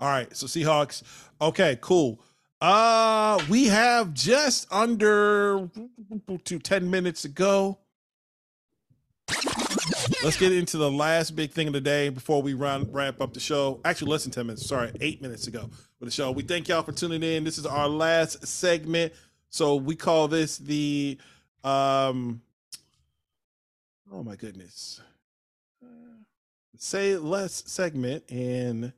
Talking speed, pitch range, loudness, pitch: 140 wpm, 135-185 Hz, -25 LUFS, 155 Hz